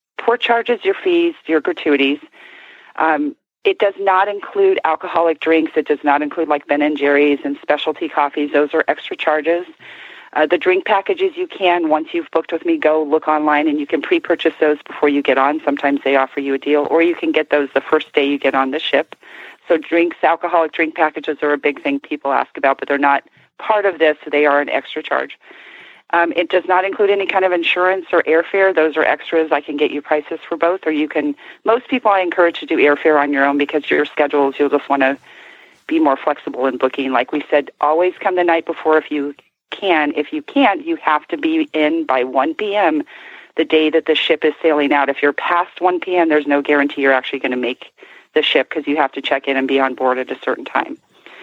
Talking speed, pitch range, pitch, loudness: 230 wpm, 145-180 Hz, 155 Hz, -16 LUFS